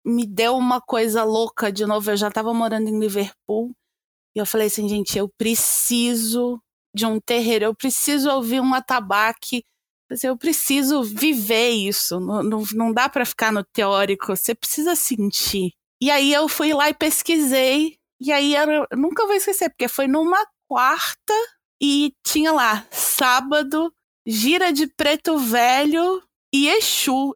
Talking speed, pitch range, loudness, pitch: 155 wpm, 220-300 Hz, -20 LUFS, 250 Hz